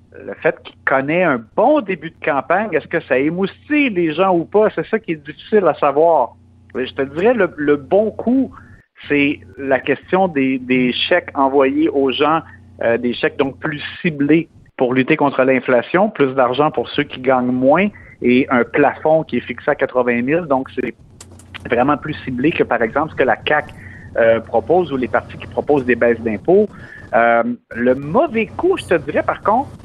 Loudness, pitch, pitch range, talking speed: -17 LUFS, 140 Hz, 120-165 Hz, 195 wpm